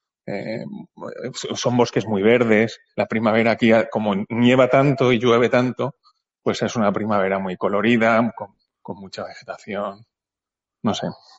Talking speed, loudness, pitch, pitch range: 135 wpm, -19 LUFS, 115 Hz, 105-120 Hz